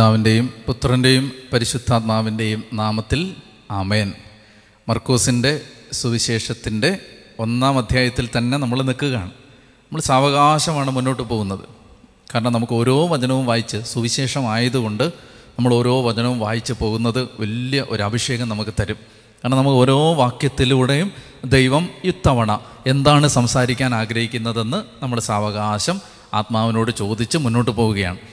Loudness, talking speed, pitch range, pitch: -19 LUFS, 100 wpm, 110-130 Hz, 120 Hz